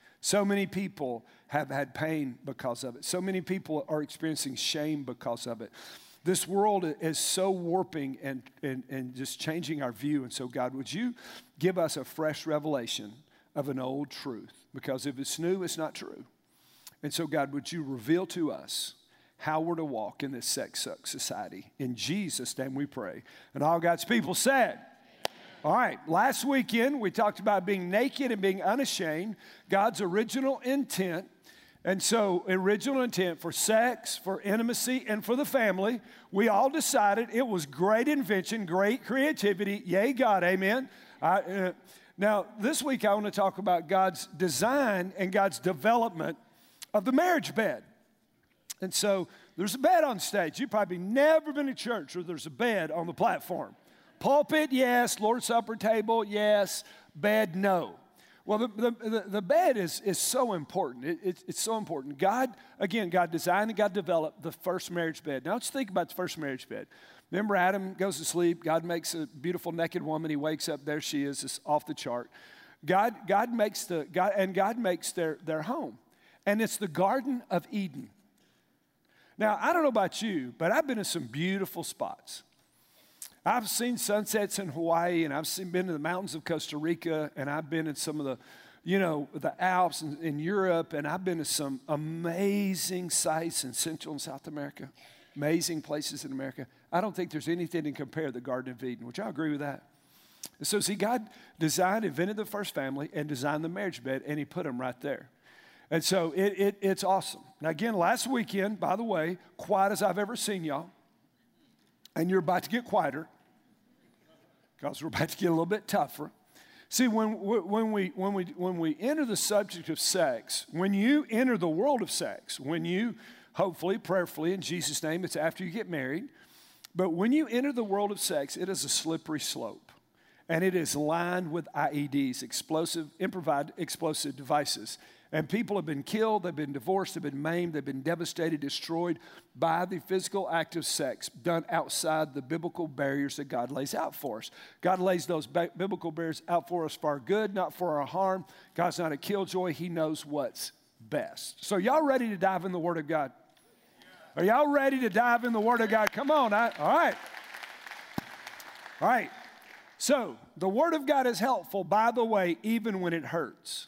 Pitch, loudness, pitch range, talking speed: 180 Hz, -30 LUFS, 155-210 Hz, 190 wpm